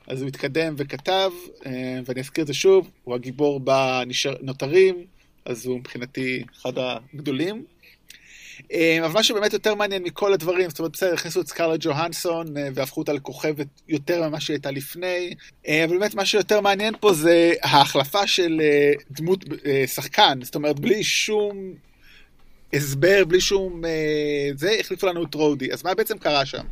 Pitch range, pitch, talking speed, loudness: 140-185 Hz, 155 Hz, 155 wpm, -22 LUFS